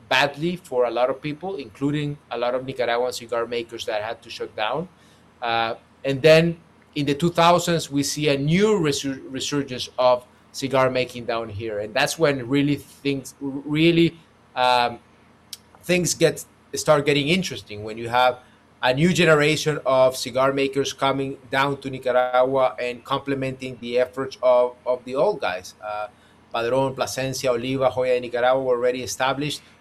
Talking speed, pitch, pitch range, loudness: 160 wpm, 130 Hz, 125-145 Hz, -22 LUFS